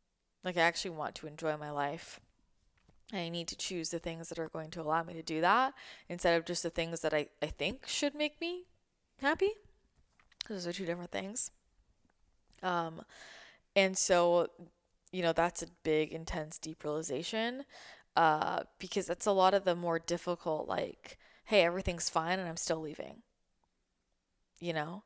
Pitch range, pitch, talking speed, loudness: 165-185 Hz, 170 Hz, 170 wpm, -34 LUFS